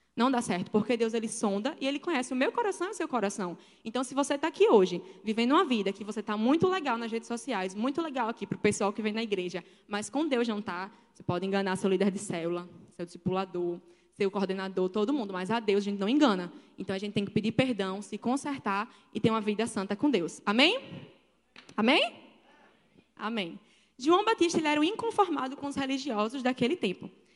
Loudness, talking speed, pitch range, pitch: -30 LUFS, 220 wpm, 195-265 Hz, 215 Hz